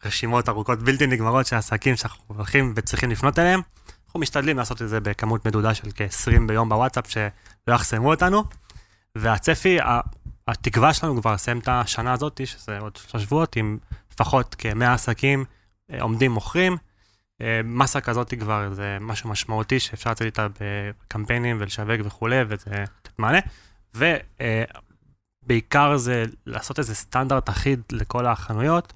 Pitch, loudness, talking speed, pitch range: 115 Hz, -23 LUFS, 135 wpm, 105-130 Hz